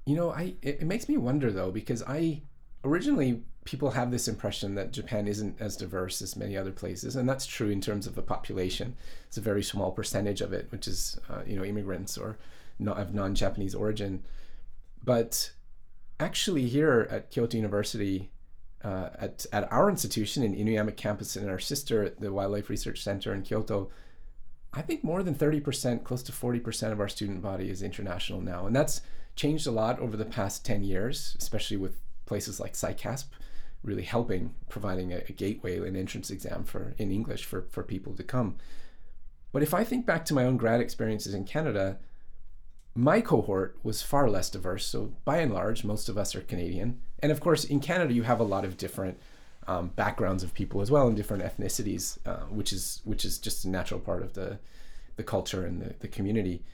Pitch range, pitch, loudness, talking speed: 95-120 Hz, 105 Hz, -31 LUFS, 200 wpm